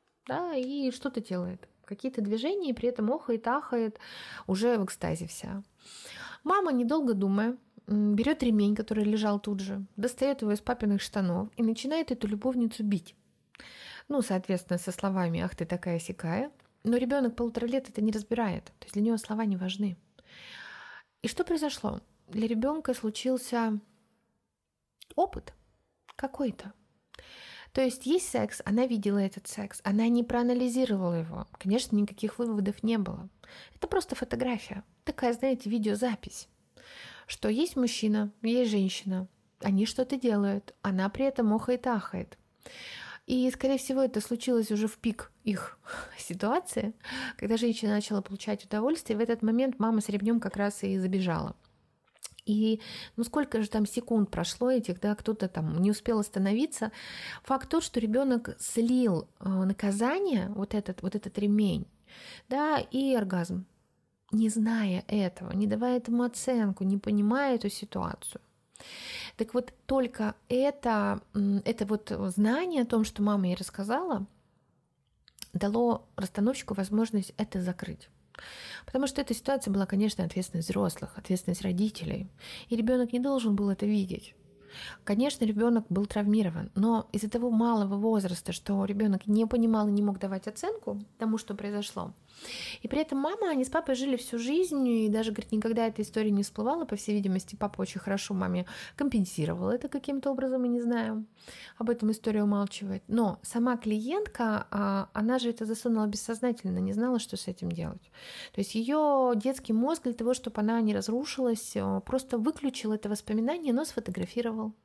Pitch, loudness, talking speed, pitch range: 220 Hz, -30 LUFS, 150 wpm, 200-245 Hz